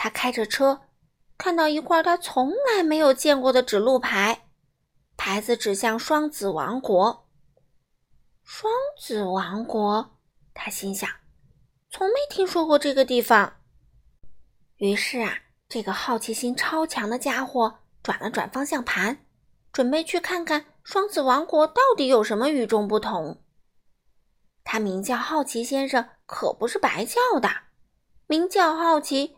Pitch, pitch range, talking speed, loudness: 255 Hz, 215-310 Hz, 200 characters per minute, -23 LUFS